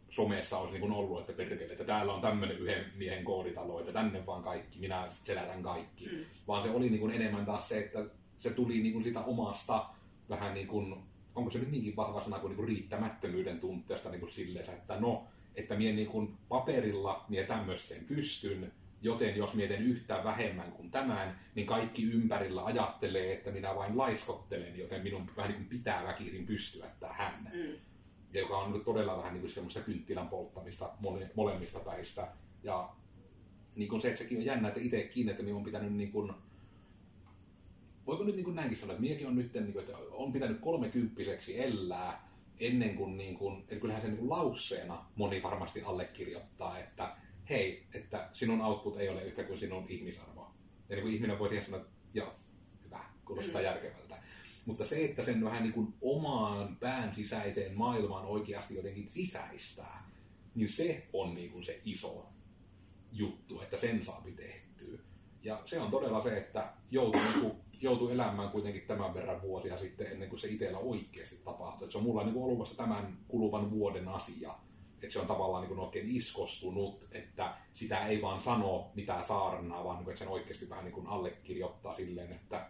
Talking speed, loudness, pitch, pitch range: 175 wpm, -38 LUFS, 105 Hz, 95-110 Hz